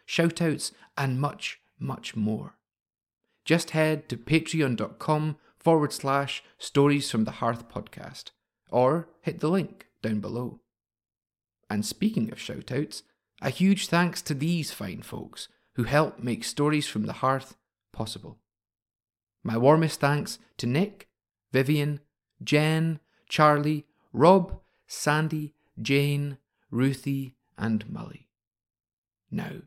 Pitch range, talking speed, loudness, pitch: 110-155 Hz, 115 wpm, -27 LUFS, 140 Hz